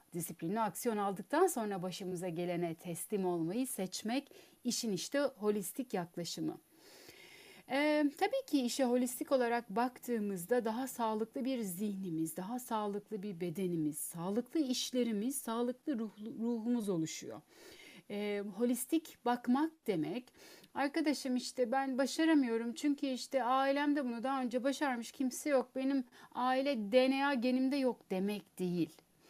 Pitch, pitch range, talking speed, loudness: 245 Hz, 205-270 Hz, 120 wpm, -36 LUFS